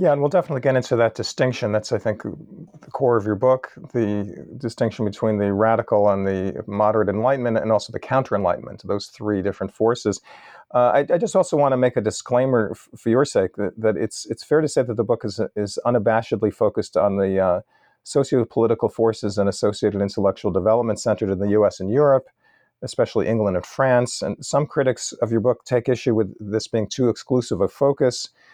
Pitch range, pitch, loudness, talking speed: 105-125 Hz, 115 Hz, -21 LUFS, 205 wpm